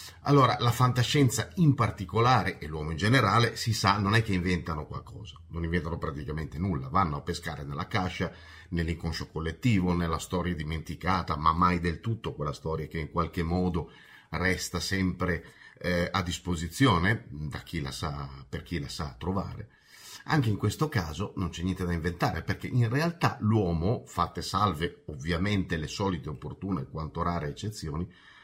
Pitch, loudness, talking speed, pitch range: 90 Hz, -29 LUFS, 160 wpm, 85-105 Hz